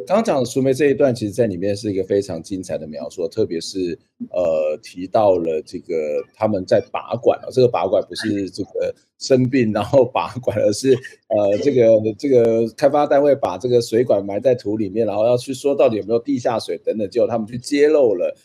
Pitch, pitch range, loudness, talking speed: 125 Hz, 110-145 Hz, -19 LUFS, 310 characters per minute